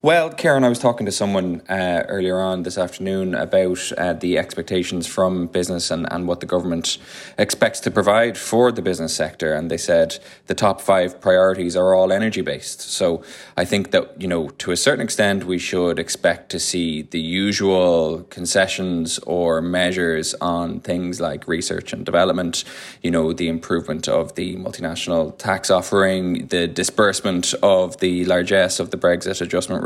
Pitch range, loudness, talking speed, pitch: 85-95 Hz, -20 LUFS, 170 wpm, 90 Hz